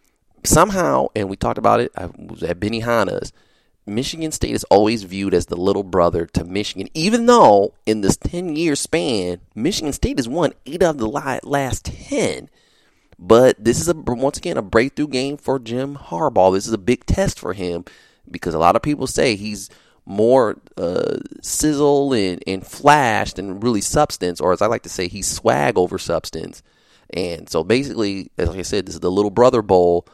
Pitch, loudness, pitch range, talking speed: 110 Hz, -18 LUFS, 95-140 Hz, 190 wpm